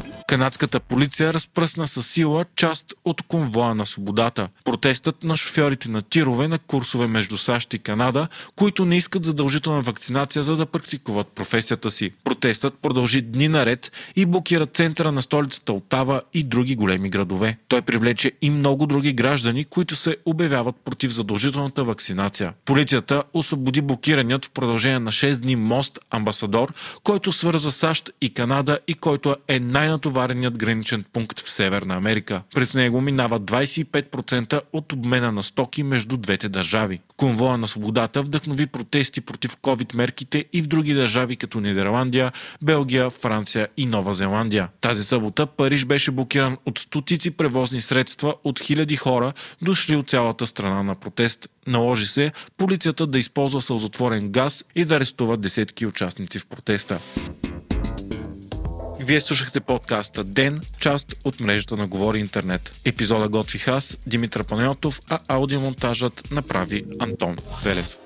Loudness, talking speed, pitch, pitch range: -22 LUFS, 145 wpm, 130 Hz, 115-145 Hz